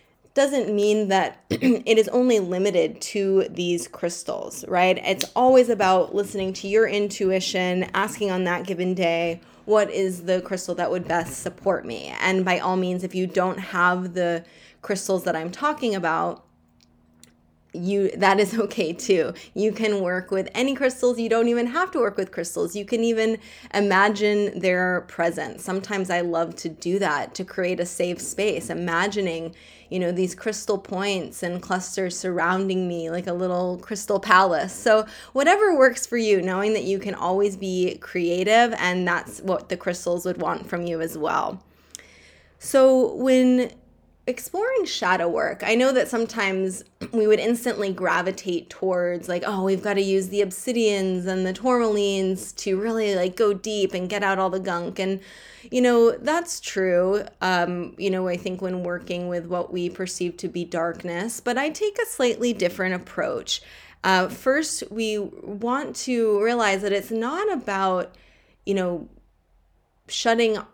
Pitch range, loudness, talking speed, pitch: 180-220 Hz, -23 LUFS, 165 wpm, 190 Hz